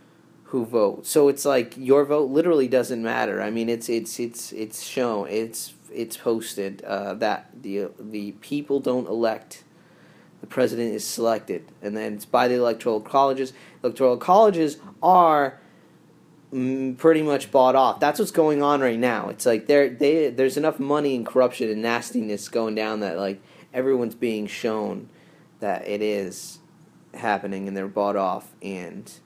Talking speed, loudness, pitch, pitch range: 160 wpm, -23 LUFS, 125 Hz, 110-145 Hz